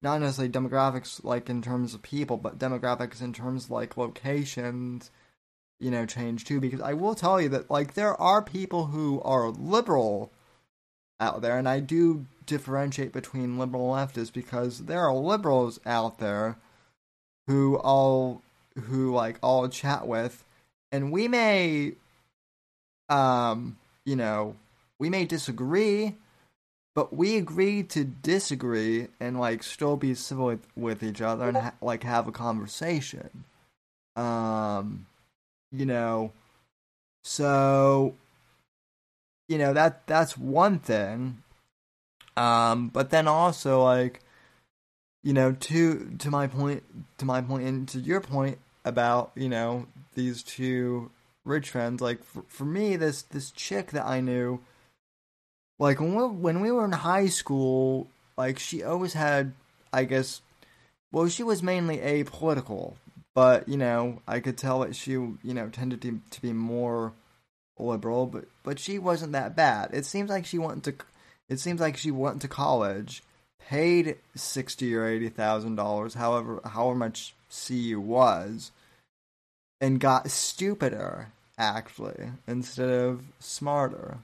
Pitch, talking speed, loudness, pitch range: 130 Hz, 140 wpm, -28 LUFS, 120-145 Hz